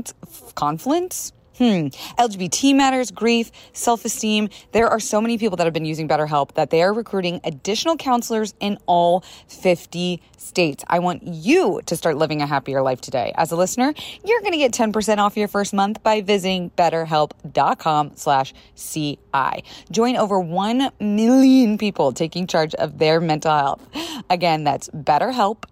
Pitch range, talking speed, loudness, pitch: 160-230 Hz, 155 wpm, -20 LUFS, 190 Hz